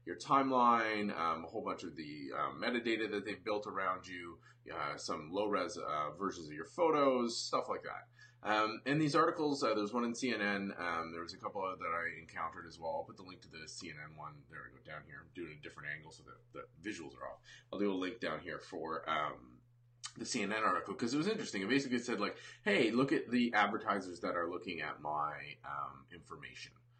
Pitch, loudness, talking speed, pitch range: 105 Hz, -37 LUFS, 225 wpm, 90-120 Hz